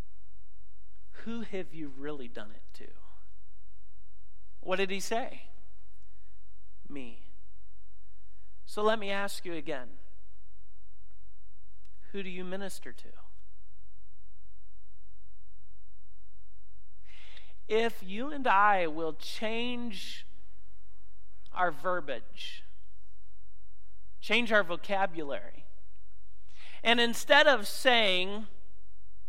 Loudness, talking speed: -30 LUFS, 80 wpm